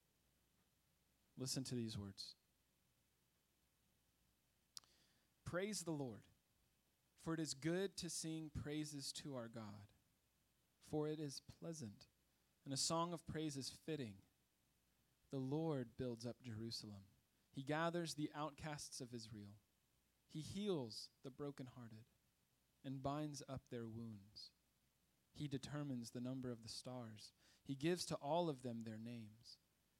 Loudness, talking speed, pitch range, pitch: -48 LUFS, 125 wpm, 110-150 Hz, 130 Hz